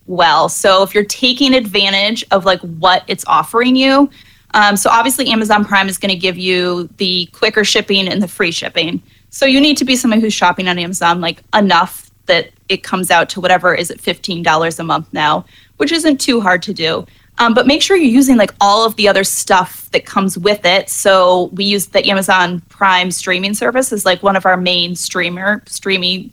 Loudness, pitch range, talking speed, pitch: -12 LUFS, 180-220 Hz, 205 wpm, 195 Hz